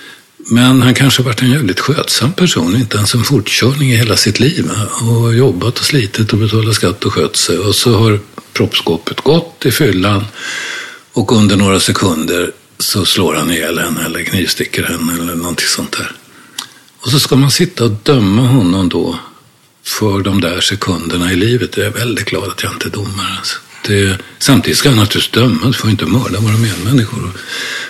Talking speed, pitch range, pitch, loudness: 185 wpm, 100-125 Hz, 115 Hz, -12 LUFS